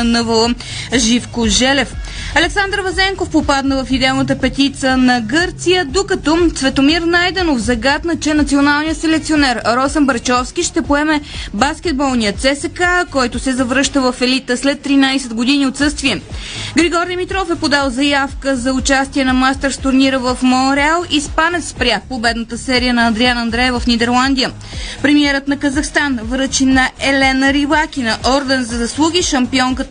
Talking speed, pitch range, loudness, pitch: 135 wpm, 255-305 Hz, -14 LUFS, 275 Hz